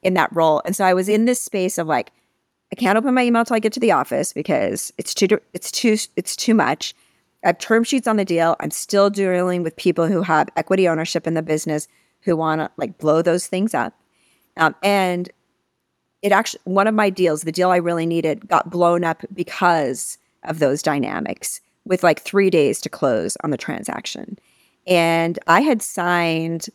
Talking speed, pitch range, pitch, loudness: 205 wpm, 165-205 Hz, 180 Hz, -19 LUFS